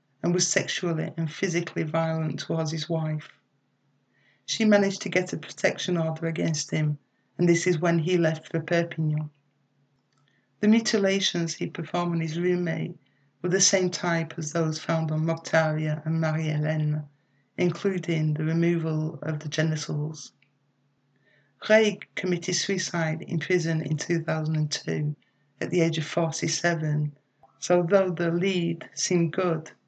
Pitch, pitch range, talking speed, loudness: 160 Hz, 150-175 Hz, 135 wpm, -26 LUFS